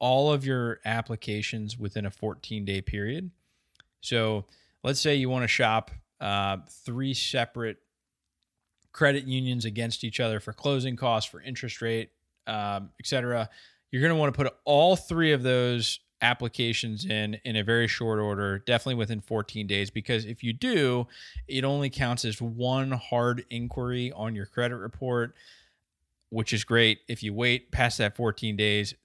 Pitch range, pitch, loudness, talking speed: 105-125 Hz, 115 Hz, -28 LUFS, 160 wpm